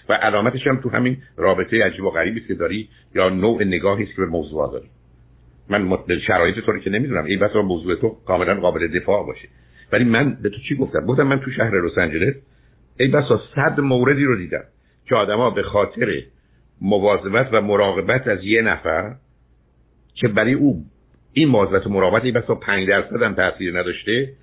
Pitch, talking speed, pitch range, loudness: 105 Hz, 180 wpm, 85-130 Hz, -19 LUFS